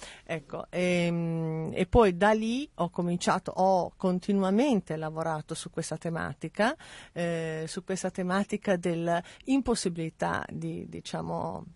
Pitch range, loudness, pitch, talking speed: 165-195 Hz, -29 LUFS, 175 Hz, 105 wpm